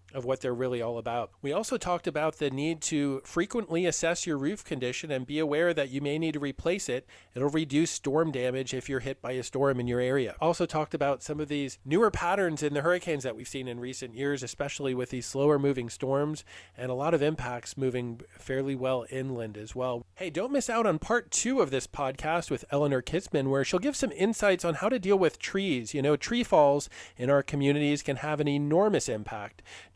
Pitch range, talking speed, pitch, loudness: 130-165 Hz, 220 wpm, 140 Hz, -29 LUFS